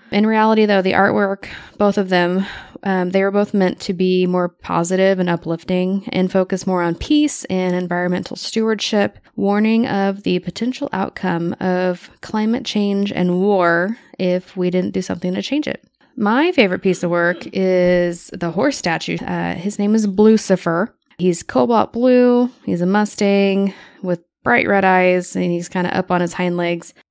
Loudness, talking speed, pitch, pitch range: -17 LUFS, 175 wpm, 190 Hz, 180-210 Hz